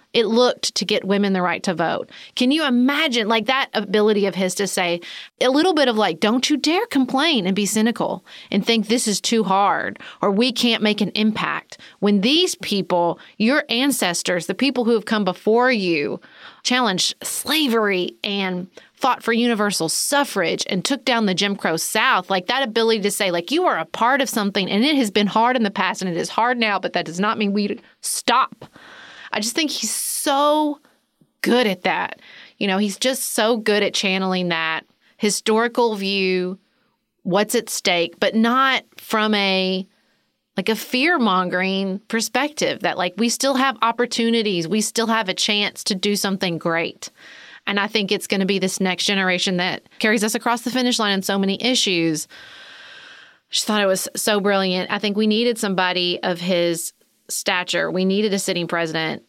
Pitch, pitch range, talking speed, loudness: 215 Hz, 190-245 Hz, 190 wpm, -20 LUFS